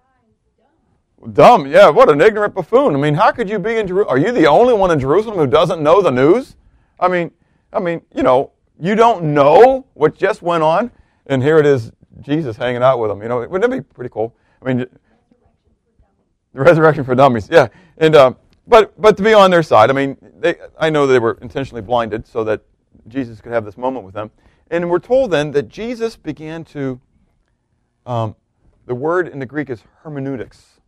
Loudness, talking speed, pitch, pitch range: -14 LUFS, 205 wpm, 140 Hz, 120-170 Hz